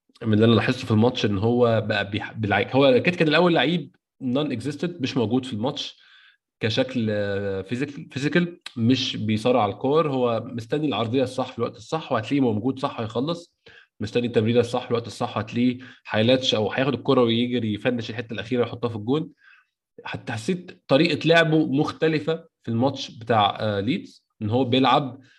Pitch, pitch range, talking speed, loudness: 125 Hz, 115-145 Hz, 160 wpm, -23 LUFS